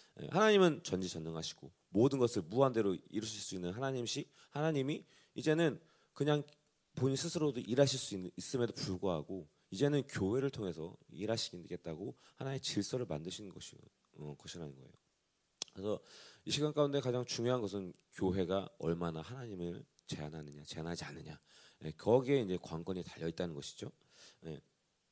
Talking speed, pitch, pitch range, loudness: 350 characters per minute, 110 Hz, 90-140 Hz, -37 LUFS